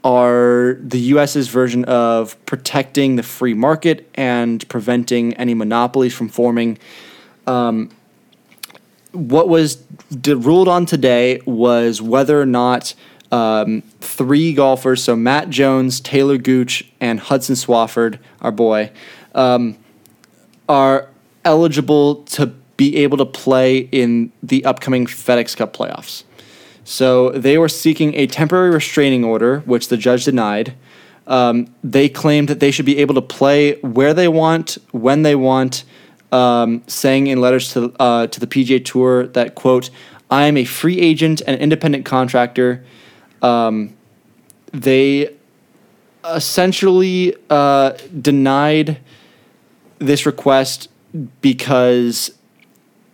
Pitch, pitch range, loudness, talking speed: 130 Hz, 120-145 Hz, -15 LUFS, 125 wpm